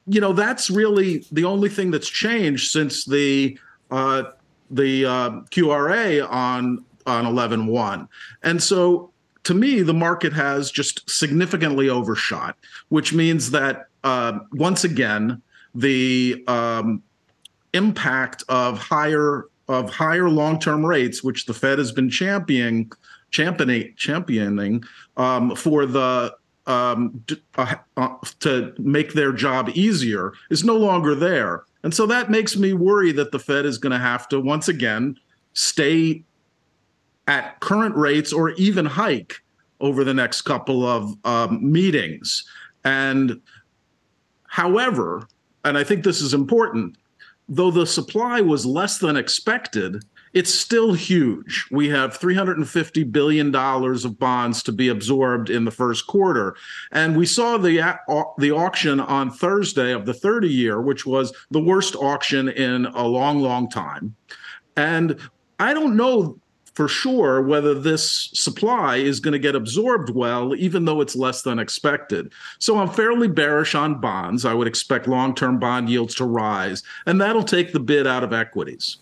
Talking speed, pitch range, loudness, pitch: 150 wpm, 125-175 Hz, -20 LUFS, 145 Hz